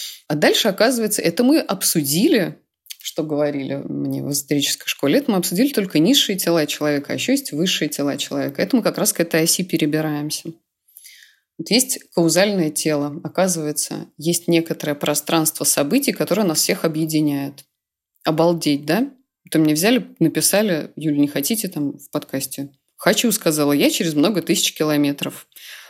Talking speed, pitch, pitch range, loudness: 155 wpm, 160 Hz, 150-190 Hz, -19 LUFS